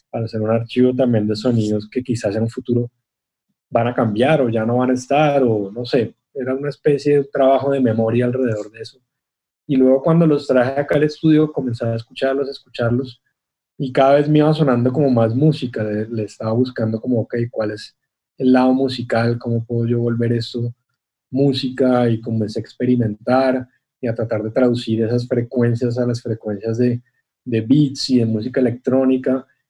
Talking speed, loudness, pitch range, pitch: 190 wpm, -18 LUFS, 115-130 Hz, 125 Hz